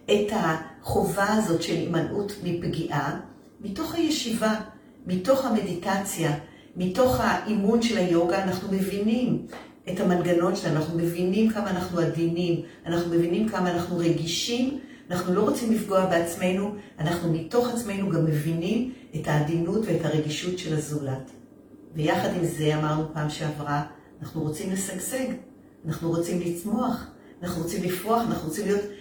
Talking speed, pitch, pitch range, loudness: 130 wpm, 180 Hz, 165-210 Hz, -26 LUFS